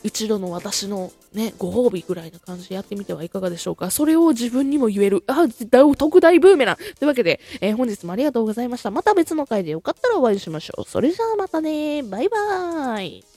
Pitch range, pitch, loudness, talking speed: 195-300 Hz, 240 Hz, -19 LUFS, 445 characters per minute